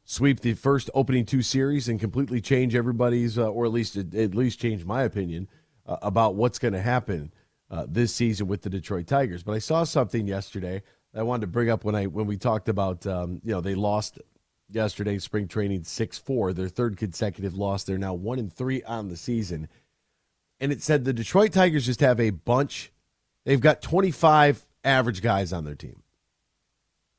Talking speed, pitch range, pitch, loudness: 195 wpm, 100-125 Hz, 115 Hz, -25 LUFS